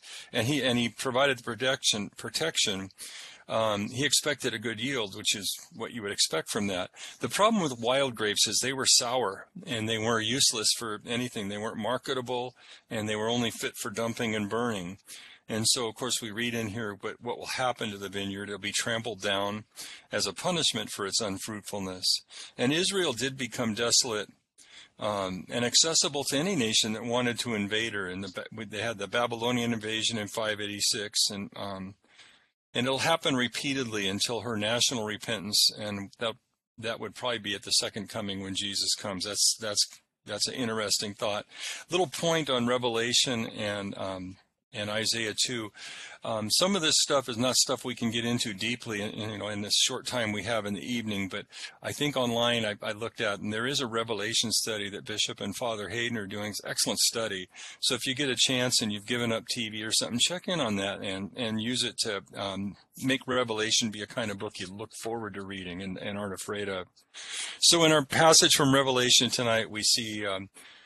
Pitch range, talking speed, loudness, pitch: 105-125 Hz, 205 wpm, -28 LUFS, 115 Hz